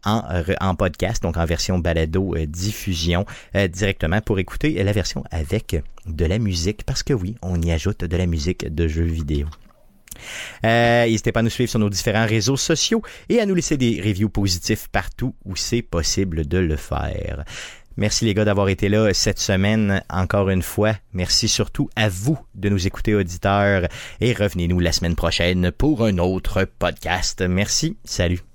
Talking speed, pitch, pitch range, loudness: 180 wpm, 100 Hz, 90-110 Hz, -21 LUFS